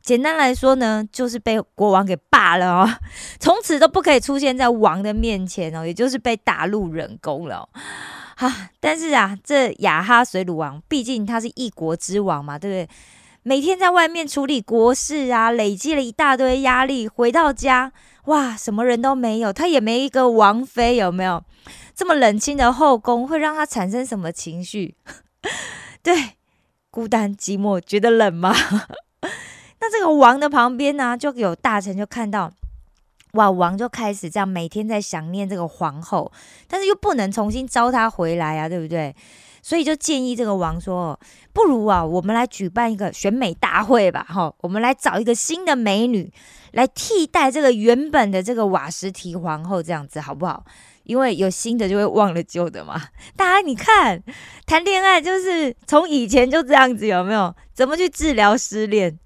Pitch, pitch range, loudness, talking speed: 230 Hz, 190-270 Hz, -19 LUFS, 265 characters per minute